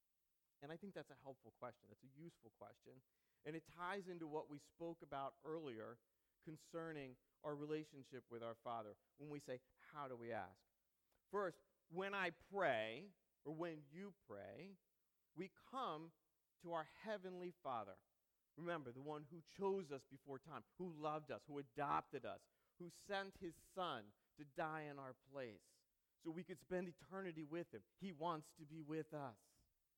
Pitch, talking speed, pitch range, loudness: 155 Hz, 165 wpm, 135-175 Hz, -51 LUFS